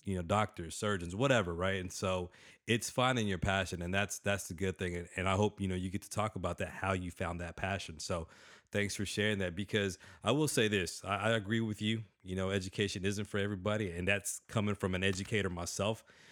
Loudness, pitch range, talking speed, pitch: -35 LUFS, 95-105 Hz, 230 wpm, 100 Hz